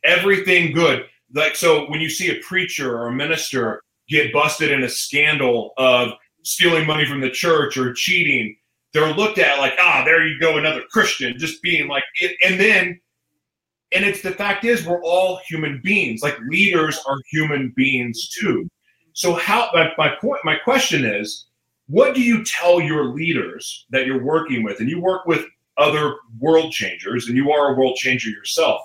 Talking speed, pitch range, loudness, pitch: 180 wpm, 130-175 Hz, -18 LUFS, 155 Hz